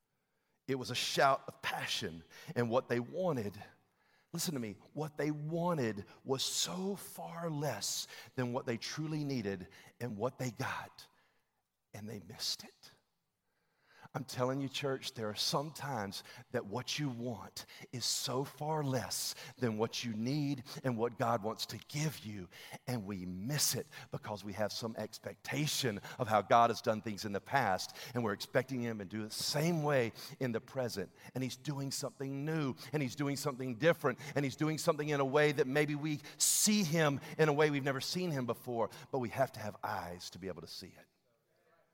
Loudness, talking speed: -36 LUFS, 190 wpm